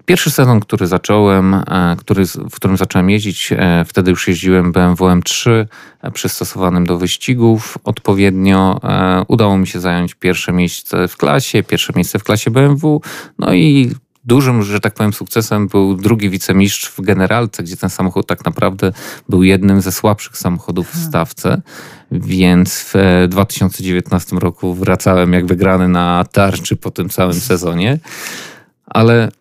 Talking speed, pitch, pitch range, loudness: 140 wpm, 95 Hz, 90-110 Hz, -13 LUFS